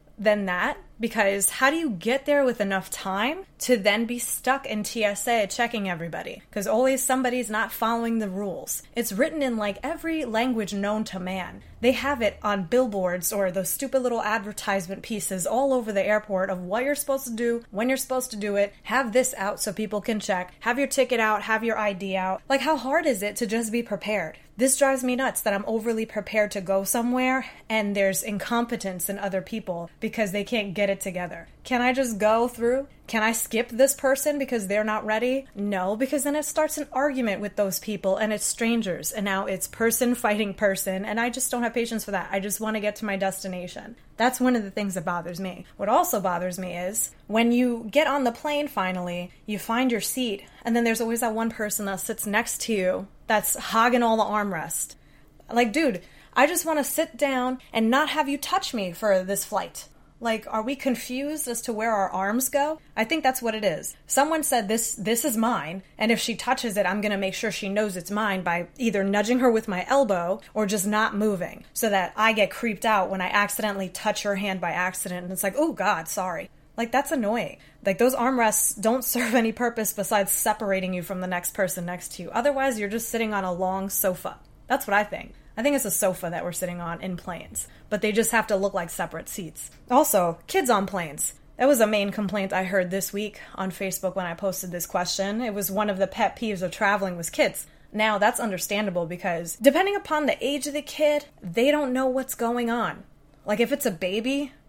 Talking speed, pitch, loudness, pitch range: 220 wpm, 215 Hz, -25 LUFS, 195-245 Hz